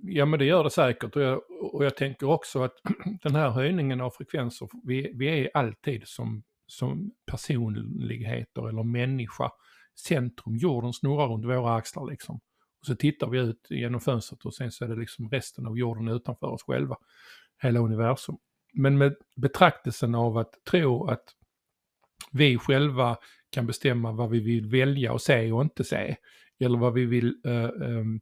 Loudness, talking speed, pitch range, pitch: -27 LUFS, 170 wpm, 120-140 Hz, 125 Hz